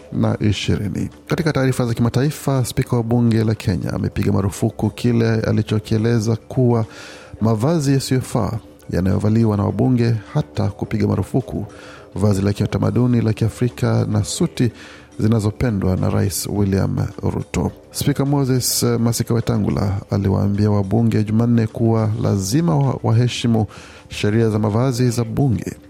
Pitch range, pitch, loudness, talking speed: 105-120 Hz, 110 Hz, -19 LUFS, 120 wpm